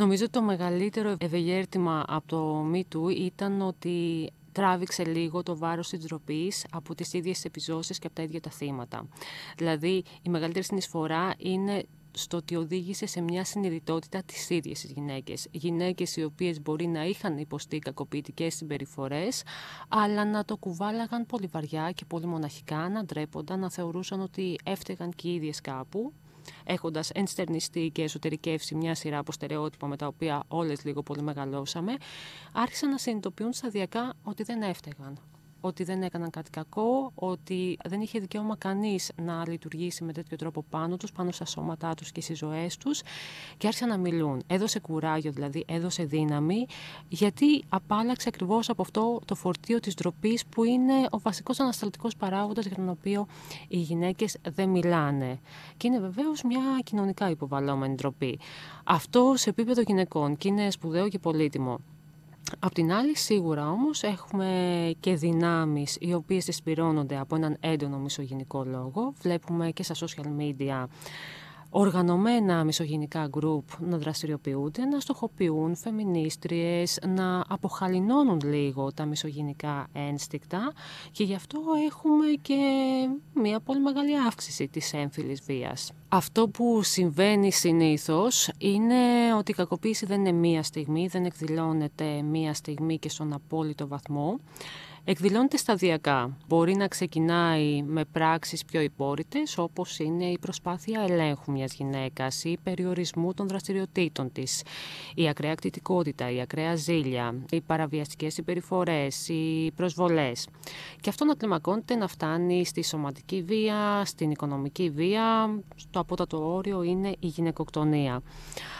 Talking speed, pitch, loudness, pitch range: 140 wpm, 170 Hz, -29 LUFS, 155-195 Hz